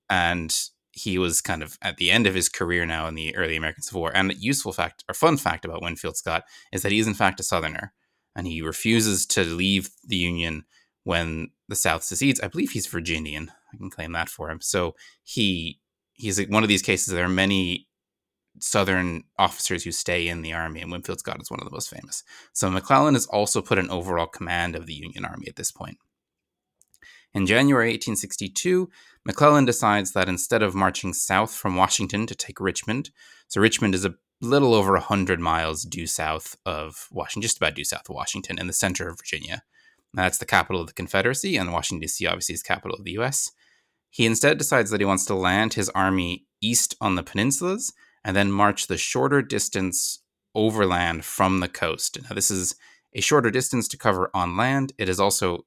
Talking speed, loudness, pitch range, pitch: 205 wpm, -23 LUFS, 85-110 Hz, 95 Hz